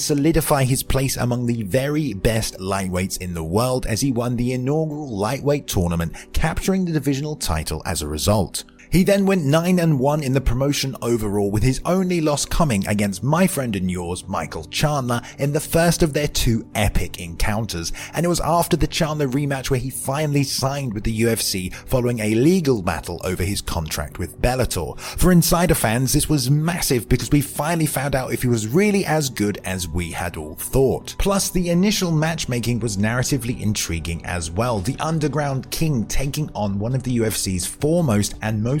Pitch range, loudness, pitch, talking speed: 100-150 Hz, -21 LUFS, 130 Hz, 185 wpm